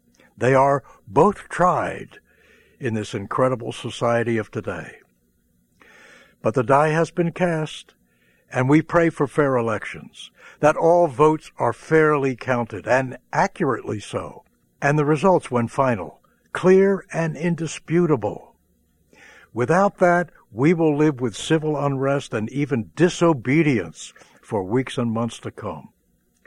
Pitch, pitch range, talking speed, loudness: 140 Hz, 120-160 Hz, 125 wpm, -21 LUFS